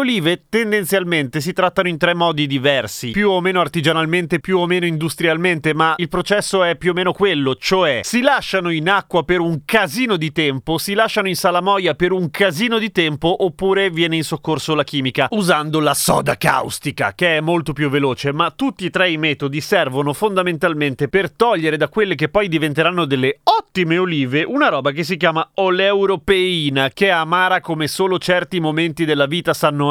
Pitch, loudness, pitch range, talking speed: 175 Hz, -17 LUFS, 155-190 Hz, 185 wpm